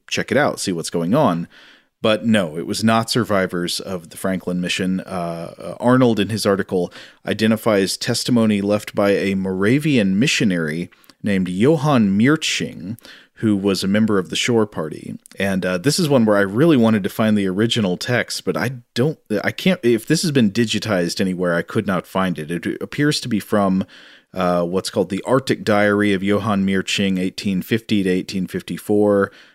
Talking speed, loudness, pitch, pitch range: 175 wpm, -19 LUFS, 100 Hz, 95-115 Hz